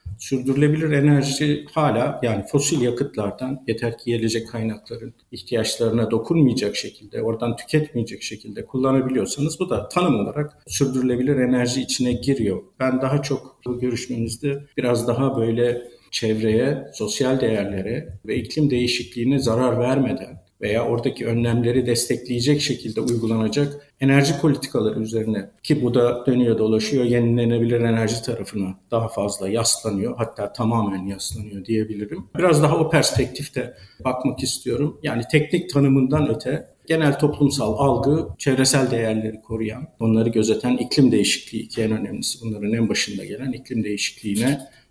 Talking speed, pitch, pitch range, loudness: 125 wpm, 120 Hz, 115-135 Hz, -21 LUFS